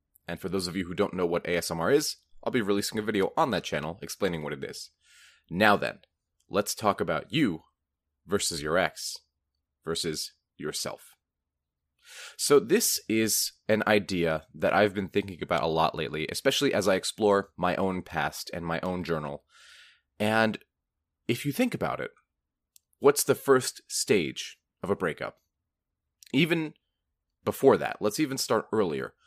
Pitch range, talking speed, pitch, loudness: 80-110 Hz, 160 wpm, 95 Hz, -28 LUFS